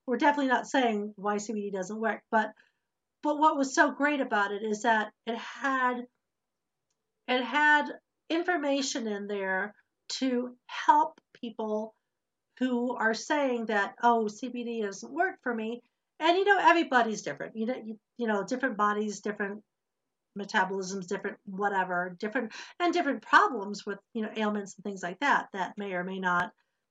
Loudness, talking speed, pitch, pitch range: -29 LUFS, 160 wpm, 230 Hz, 205-265 Hz